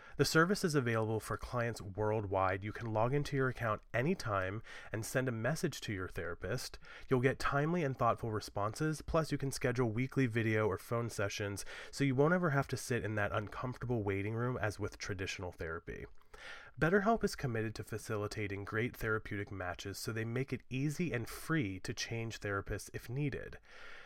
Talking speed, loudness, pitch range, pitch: 180 wpm, -36 LUFS, 105-140 Hz, 115 Hz